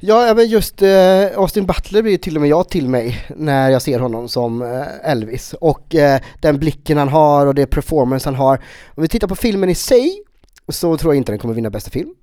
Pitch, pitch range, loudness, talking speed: 155 Hz, 135-190 Hz, -15 LUFS, 215 wpm